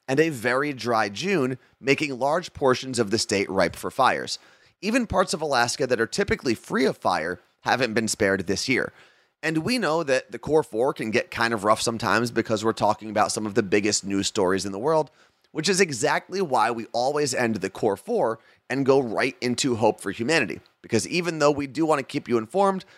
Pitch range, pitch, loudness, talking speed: 110-150 Hz, 125 Hz, -24 LUFS, 215 wpm